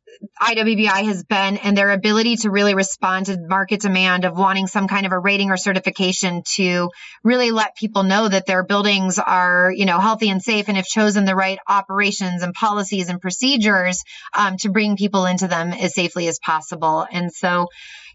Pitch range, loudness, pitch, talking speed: 185-205 Hz, -18 LUFS, 195 Hz, 190 wpm